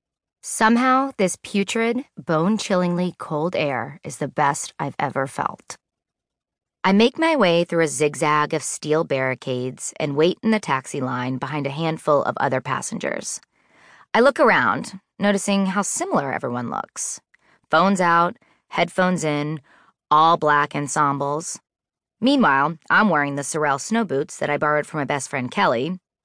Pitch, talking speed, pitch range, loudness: 160 Hz, 145 wpm, 145-195 Hz, -21 LUFS